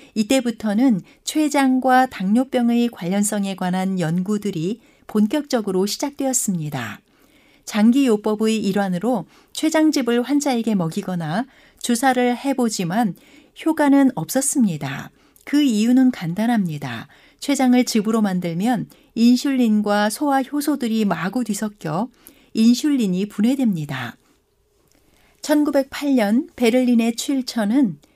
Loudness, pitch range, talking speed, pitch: -20 LUFS, 205-270 Hz, 255 characters per minute, 235 Hz